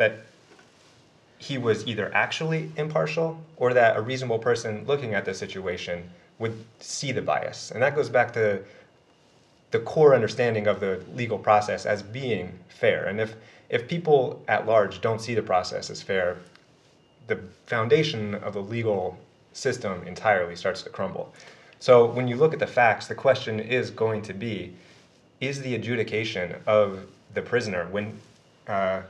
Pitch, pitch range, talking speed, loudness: 110 Hz, 105-130 Hz, 160 wpm, -25 LUFS